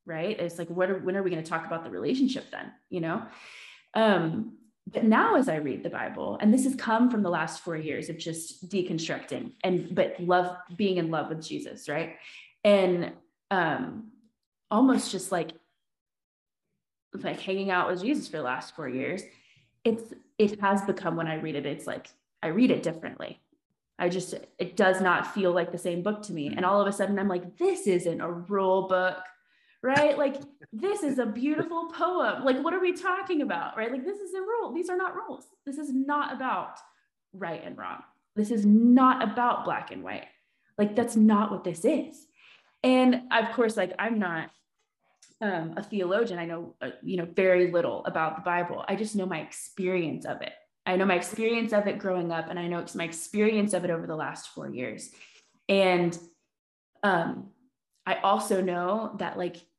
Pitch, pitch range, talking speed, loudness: 195 Hz, 175-245 Hz, 195 wpm, -28 LUFS